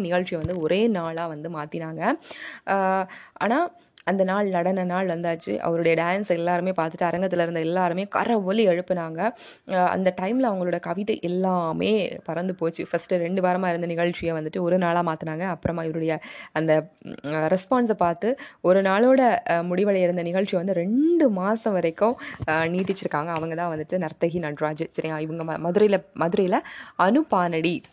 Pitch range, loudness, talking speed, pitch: 165-195 Hz, -24 LUFS, 120 wpm, 180 Hz